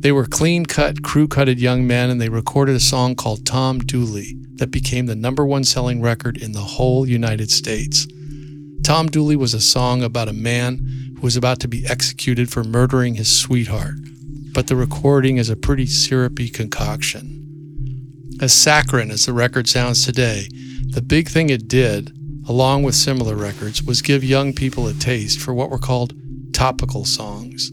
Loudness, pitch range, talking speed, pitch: -17 LUFS, 125-140 Hz, 175 wpm, 130 Hz